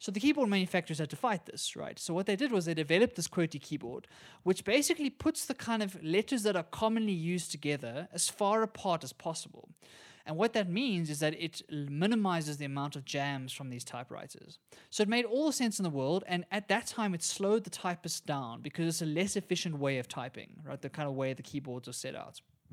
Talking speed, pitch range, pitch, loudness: 230 wpm, 150-210 Hz, 175 Hz, -33 LUFS